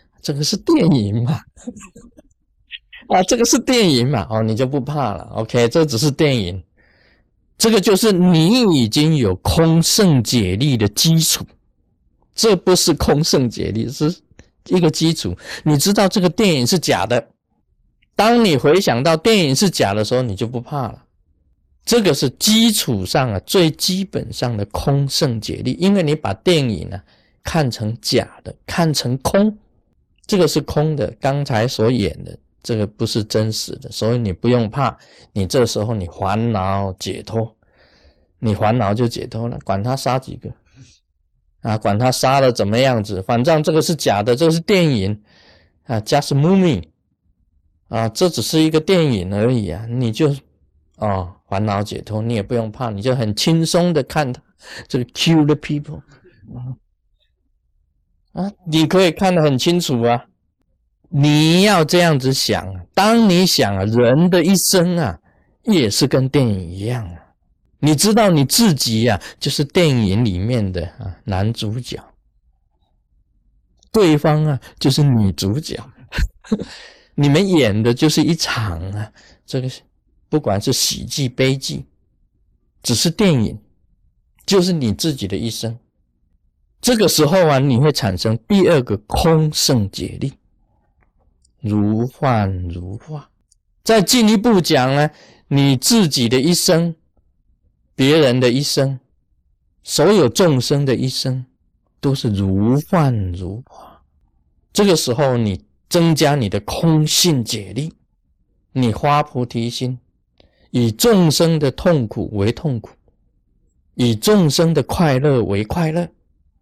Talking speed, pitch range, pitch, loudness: 210 characters per minute, 105-160 Hz, 125 Hz, -16 LUFS